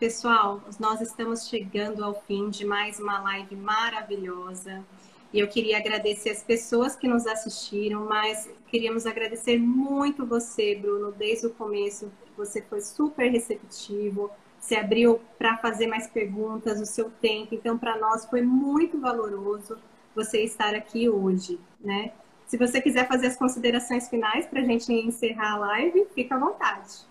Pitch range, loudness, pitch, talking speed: 210-235 Hz, -26 LUFS, 220 Hz, 155 wpm